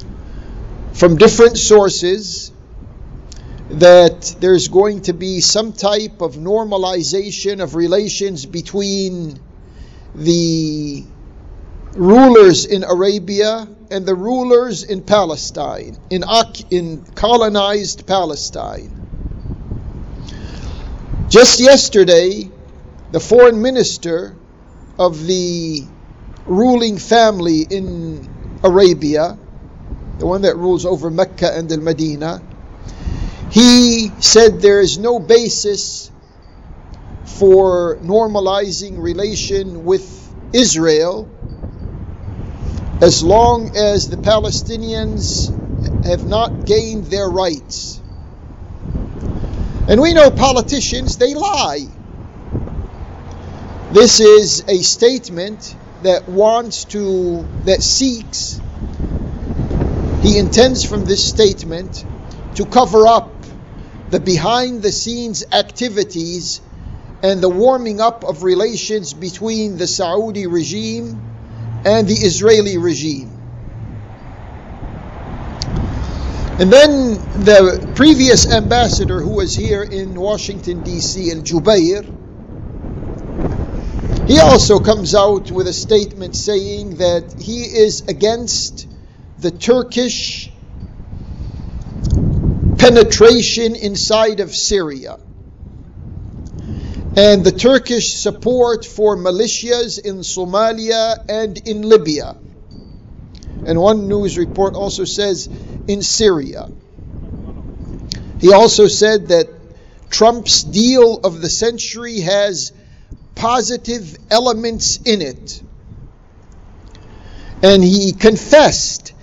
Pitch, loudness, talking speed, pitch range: 190 Hz, -13 LUFS, 90 wpm, 155-215 Hz